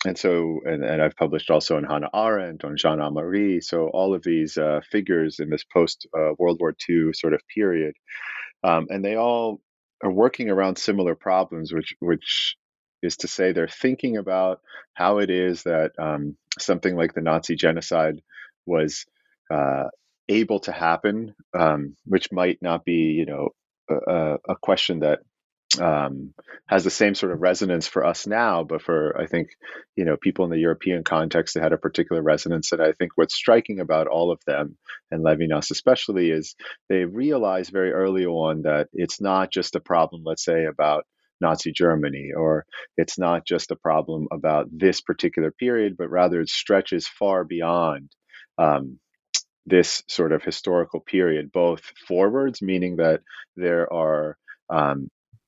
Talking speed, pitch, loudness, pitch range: 170 wpm, 85 Hz, -23 LUFS, 80-95 Hz